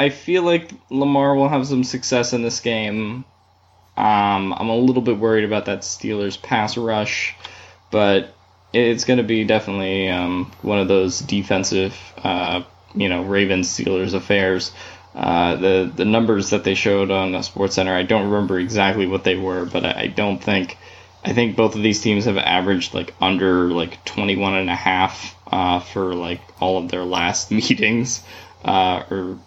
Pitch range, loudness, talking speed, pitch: 95-110 Hz, -19 LUFS, 175 wpm, 95 Hz